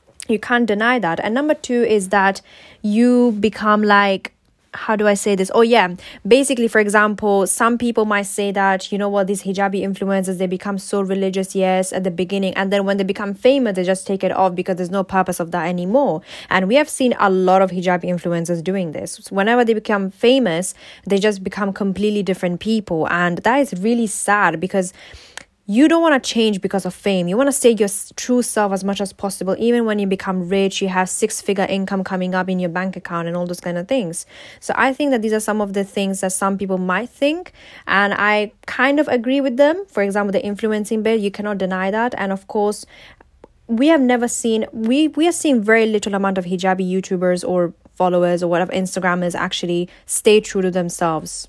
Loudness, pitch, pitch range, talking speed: -18 LUFS, 200 Hz, 185-225 Hz, 220 wpm